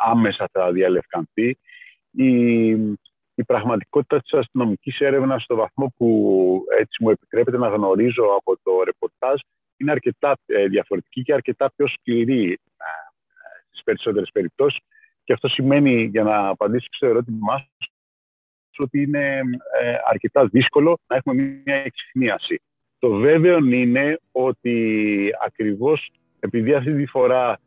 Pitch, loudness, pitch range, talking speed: 130 Hz, -20 LUFS, 110-145 Hz, 120 wpm